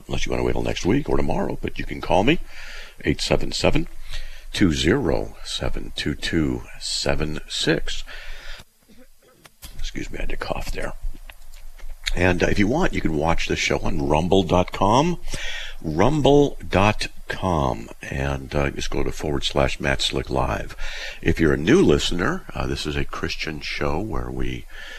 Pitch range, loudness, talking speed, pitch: 65-90 Hz, -23 LUFS, 145 wpm, 70 Hz